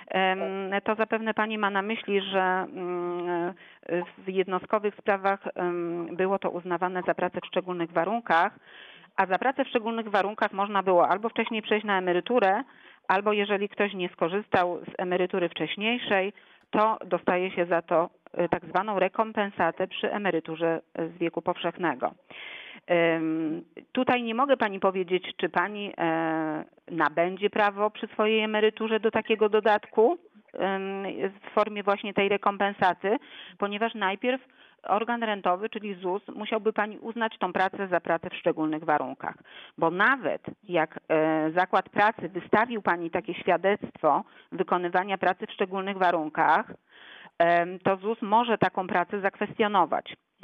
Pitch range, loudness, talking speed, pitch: 175-215 Hz, -27 LUFS, 130 wpm, 195 Hz